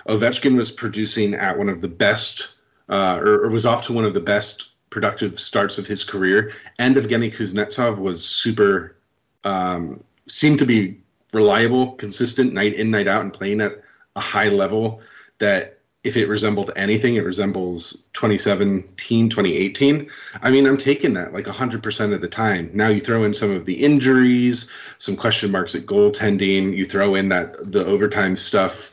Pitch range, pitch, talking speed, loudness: 100-120 Hz, 110 Hz, 170 wpm, -19 LUFS